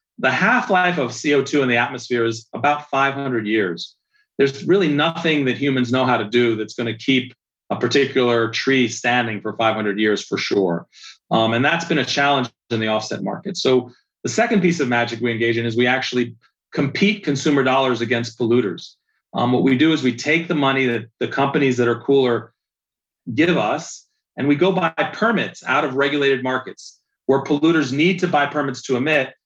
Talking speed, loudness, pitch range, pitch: 195 wpm, -19 LUFS, 120-145 Hz, 130 Hz